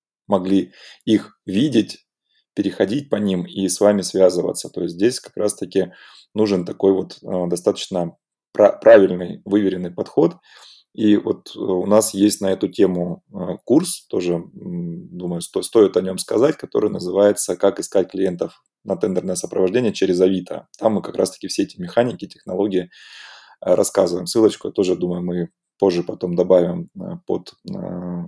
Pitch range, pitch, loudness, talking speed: 90-105 Hz, 95 Hz, -19 LUFS, 135 wpm